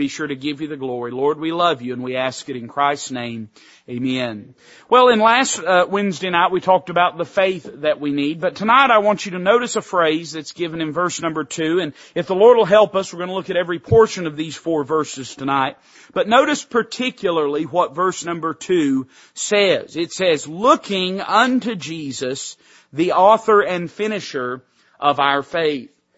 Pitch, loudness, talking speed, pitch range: 170 Hz, -18 LUFS, 200 wpm, 145-200 Hz